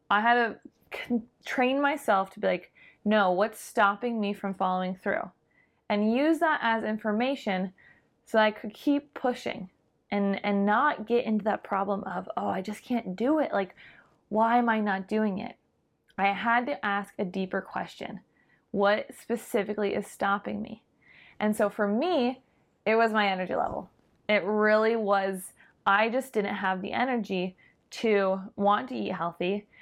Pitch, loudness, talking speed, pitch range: 210 Hz, -28 LUFS, 165 wpm, 200-235 Hz